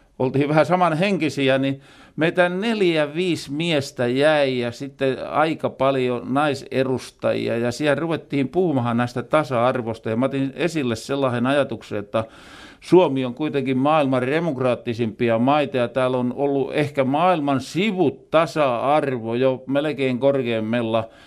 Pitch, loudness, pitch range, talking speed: 135 Hz, -21 LUFS, 125-150 Hz, 125 wpm